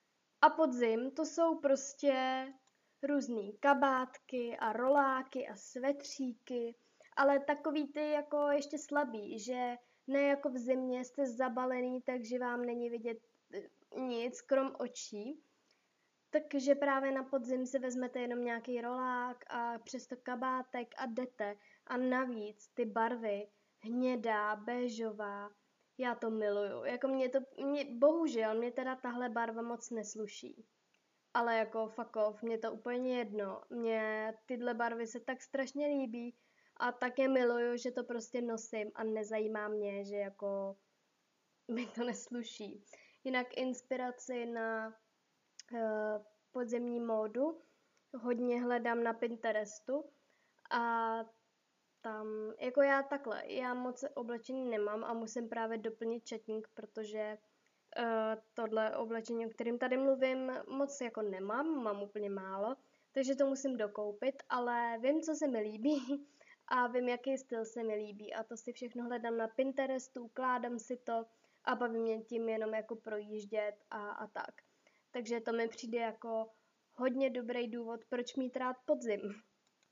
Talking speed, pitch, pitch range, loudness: 135 wpm, 240 Hz, 225-260 Hz, -38 LUFS